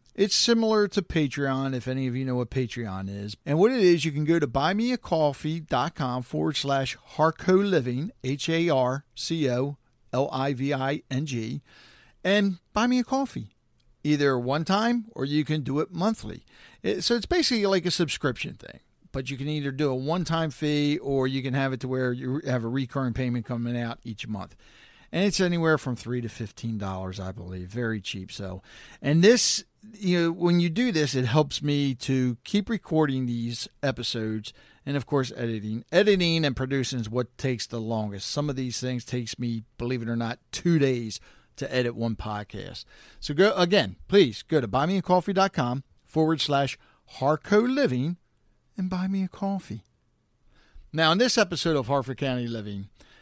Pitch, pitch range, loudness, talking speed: 140 Hz, 120-170 Hz, -26 LUFS, 185 wpm